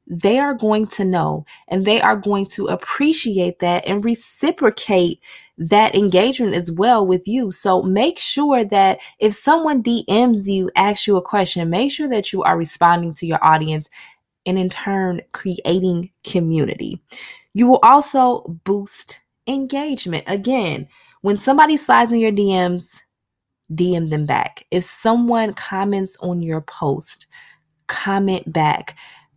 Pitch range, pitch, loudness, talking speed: 175-235 Hz, 195 Hz, -17 LUFS, 140 wpm